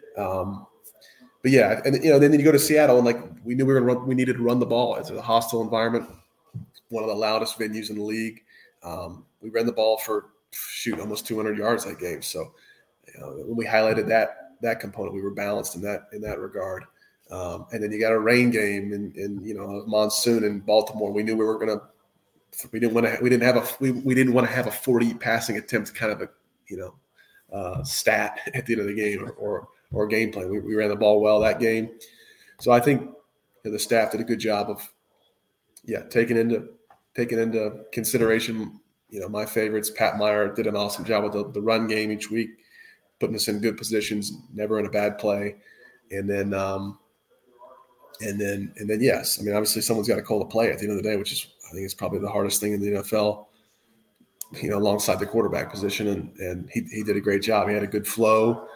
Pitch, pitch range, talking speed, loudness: 110 Hz, 105-115 Hz, 235 wpm, -24 LUFS